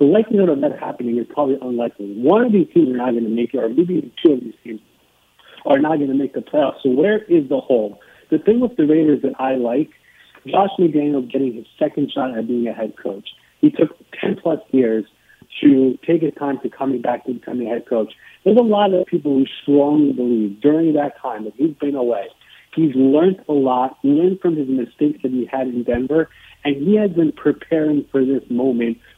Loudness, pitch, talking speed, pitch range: -18 LUFS, 145 Hz, 220 wpm, 125-165 Hz